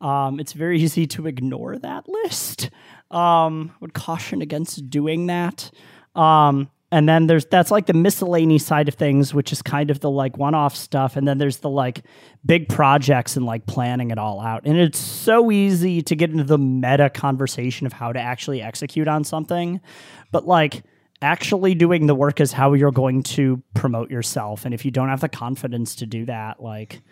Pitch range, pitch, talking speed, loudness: 130-165 Hz, 145 Hz, 195 wpm, -20 LUFS